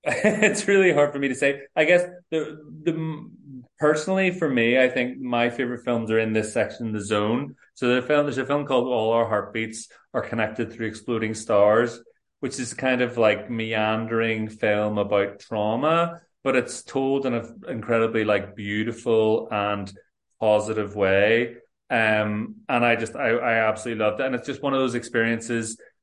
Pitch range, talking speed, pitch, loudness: 110-135 Hz, 180 wpm, 115 Hz, -23 LUFS